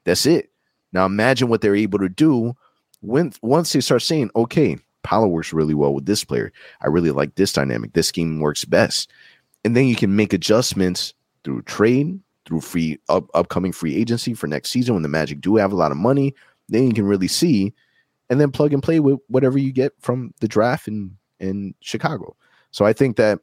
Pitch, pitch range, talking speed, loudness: 105 Hz, 90-130 Hz, 205 wpm, -19 LUFS